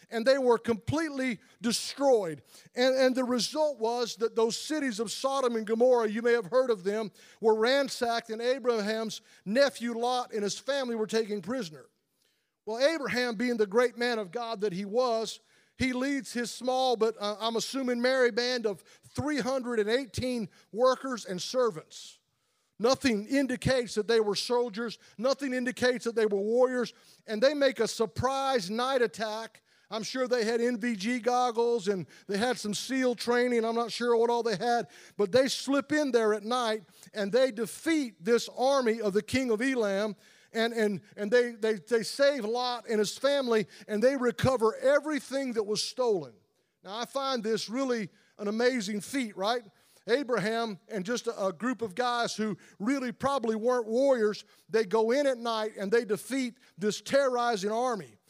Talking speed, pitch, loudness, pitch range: 170 wpm, 235 Hz, -29 LUFS, 215-255 Hz